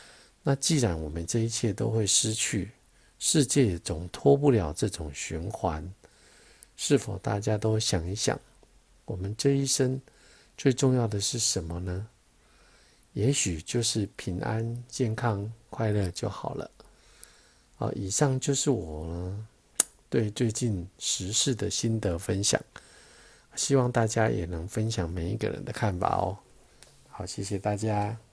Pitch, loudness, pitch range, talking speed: 110 Hz, -28 LUFS, 90-120 Hz, 200 characters per minute